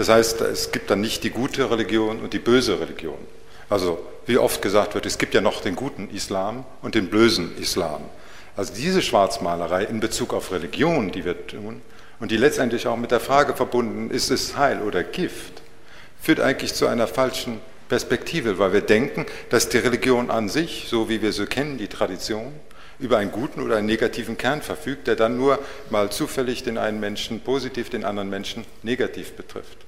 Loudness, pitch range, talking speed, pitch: -23 LUFS, 105-125 Hz, 195 wpm, 115 Hz